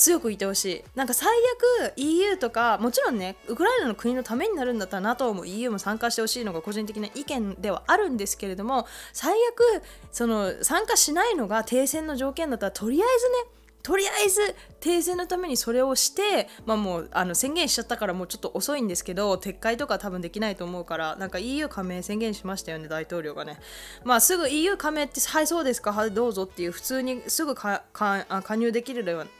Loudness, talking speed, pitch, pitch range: -25 LUFS, 445 characters per minute, 235 Hz, 200-305 Hz